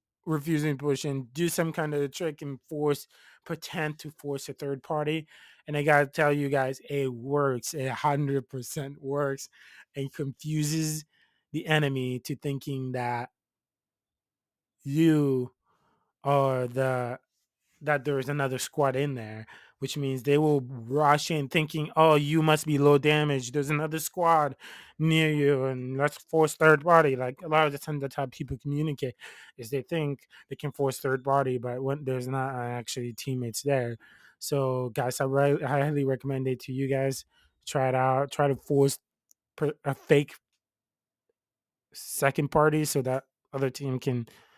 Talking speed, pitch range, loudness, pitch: 165 wpm, 130-150 Hz, -28 LUFS, 140 Hz